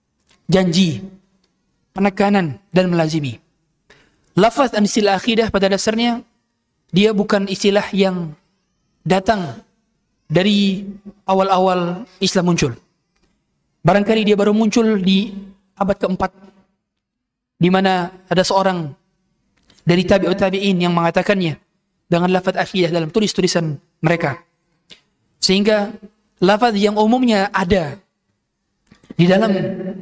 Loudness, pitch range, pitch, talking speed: -17 LUFS, 180-205 Hz, 190 Hz, 95 wpm